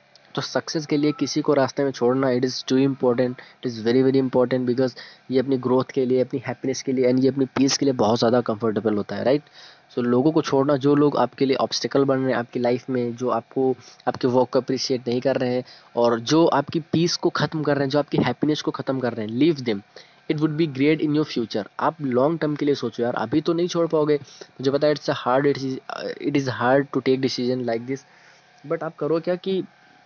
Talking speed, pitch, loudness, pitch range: 250 wpm, 135 Hz, -22 LUFS, 125-150 Hz